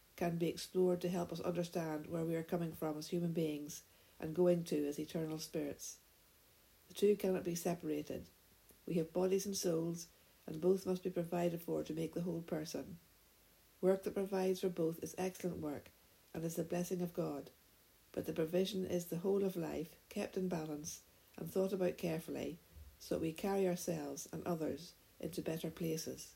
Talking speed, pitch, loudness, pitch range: 185 wpm, 170 Hz, -40 LUFS, 155-180 Hz